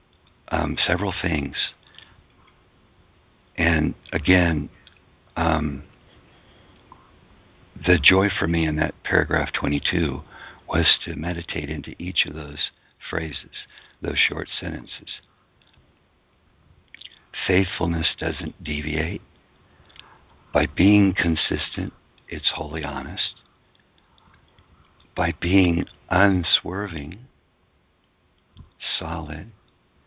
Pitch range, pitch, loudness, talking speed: 75-95 Hz, 85 Hz, -23 LUFS, 75 wpm